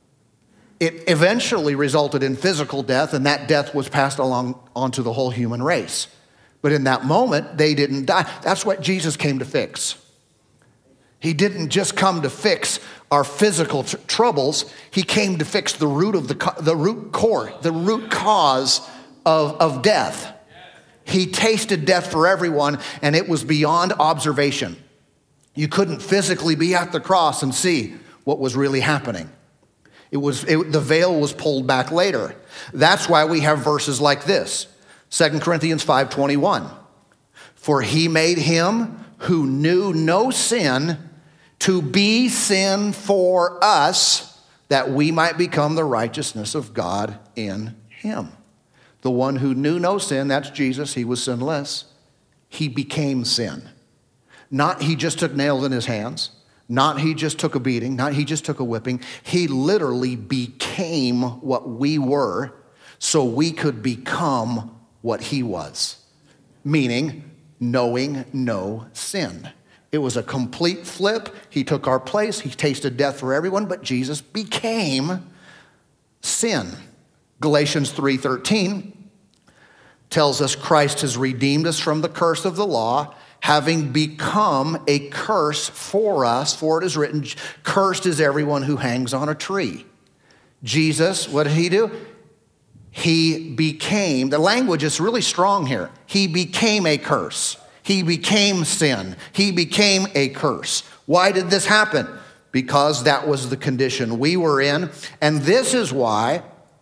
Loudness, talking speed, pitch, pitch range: -20 LUFS, 150 wpm, 150 Hz, 135-175 Hz